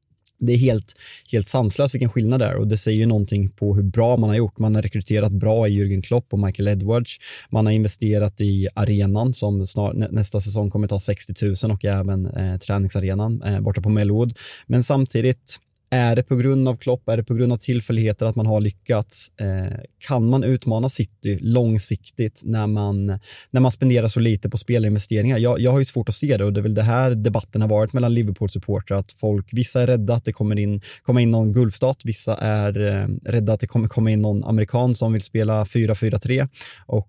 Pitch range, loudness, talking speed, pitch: 105-120 Hz, -21 LUFS, 210 wpm, 110 Hz